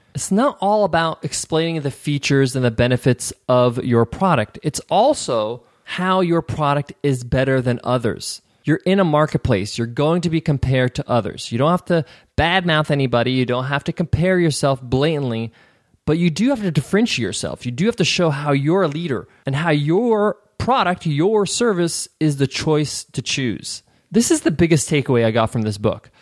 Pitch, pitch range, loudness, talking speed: 150 Hz, 125-170 Hz, -19 LUFS, 190 wpm